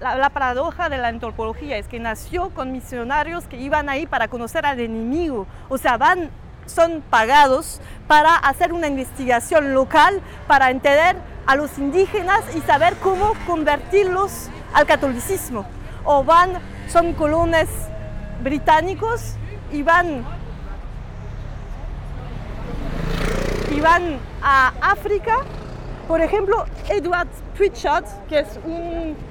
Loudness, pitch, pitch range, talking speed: -19 LUFS, 310 Hz, 270-345 Hz, 115 wpm